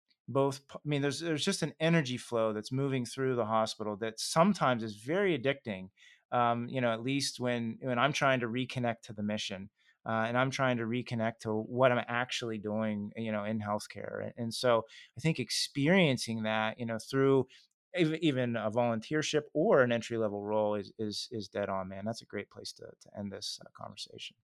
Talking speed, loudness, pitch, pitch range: 195 wpm, -32 LUFS, 120 Hz, 110-135 Hz